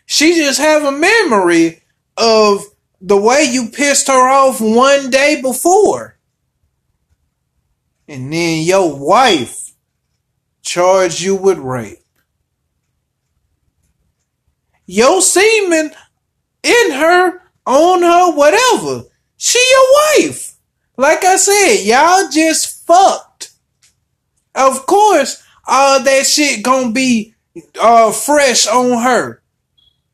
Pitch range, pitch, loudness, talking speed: 220-345 Hz, 270 Hz, -11 LUFS, 100 wpm